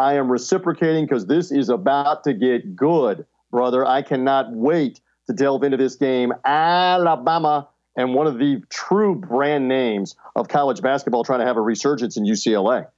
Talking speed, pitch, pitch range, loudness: 170 wpm, 140 Hz, 130-165 Hz, -20 LUFS